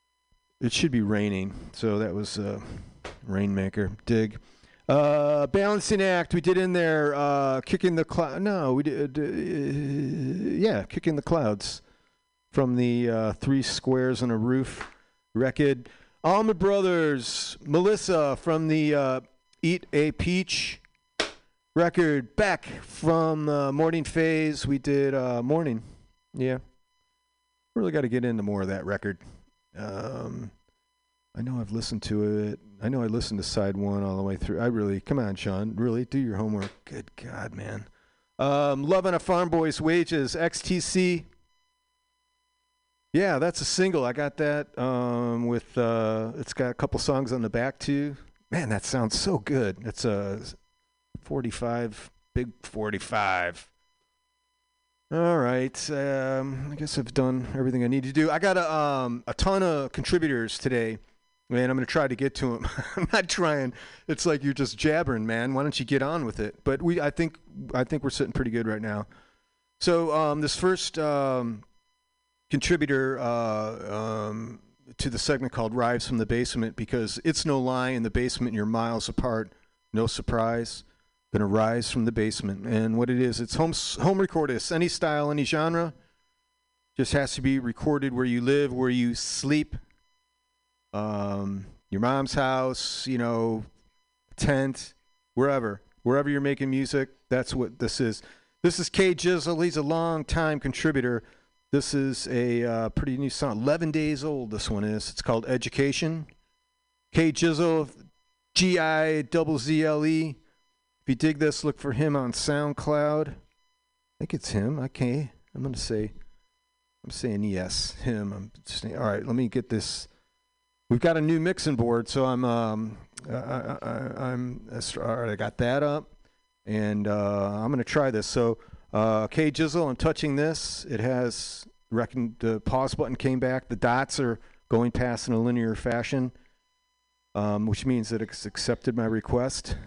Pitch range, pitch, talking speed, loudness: 115-160 Hz, 135 Hz, 165 wpm, -27 LUFS